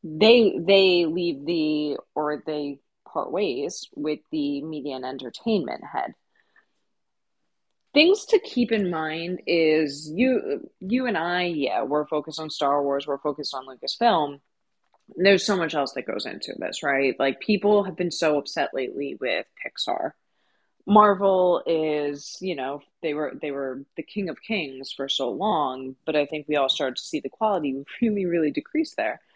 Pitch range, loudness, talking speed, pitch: 145-195 Hz, -24 LUFS, 165 wpm, 155 Hz